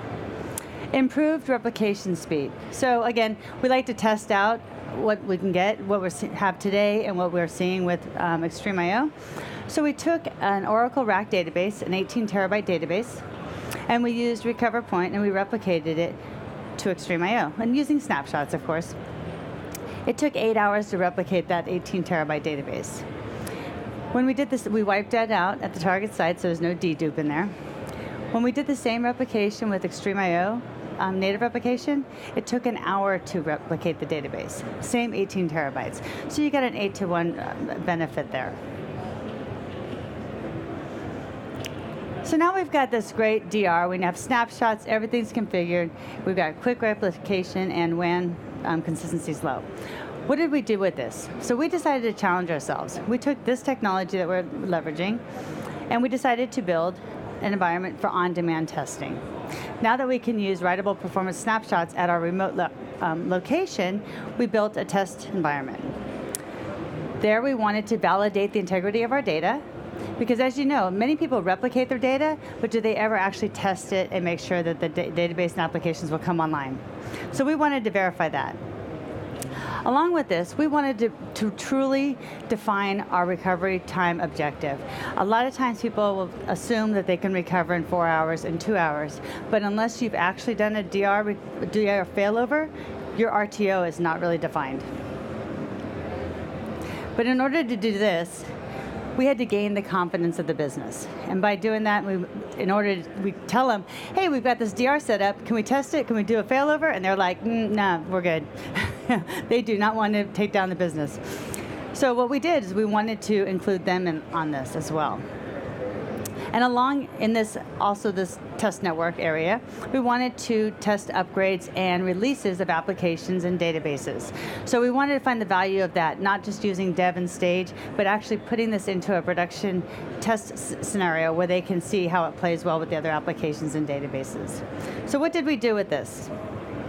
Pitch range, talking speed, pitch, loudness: 175-235 Hz, 180 wpm, 200 Hz, -26 LUFS